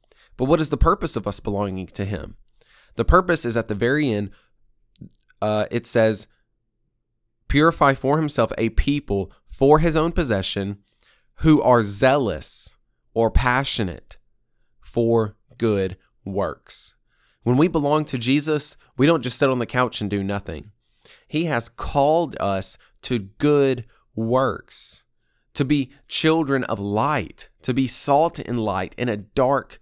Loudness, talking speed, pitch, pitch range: -21 LUFS, 145 wpm, 120 Hz, 105-145 Hz